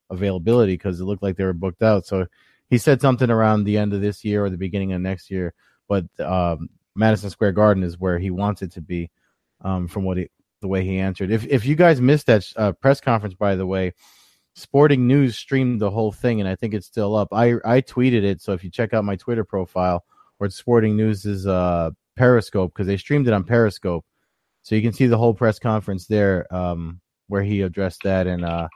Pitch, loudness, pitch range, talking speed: 100 Hz, -20 LUFS, 95-115 Hz, 230 wpm